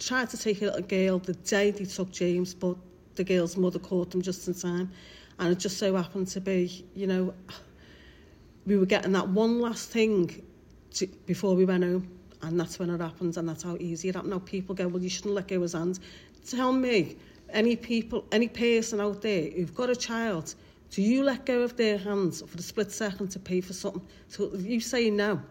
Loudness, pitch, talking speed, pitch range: -29 LUFS, 190 Hz, 220 wpm, 180-210 Hz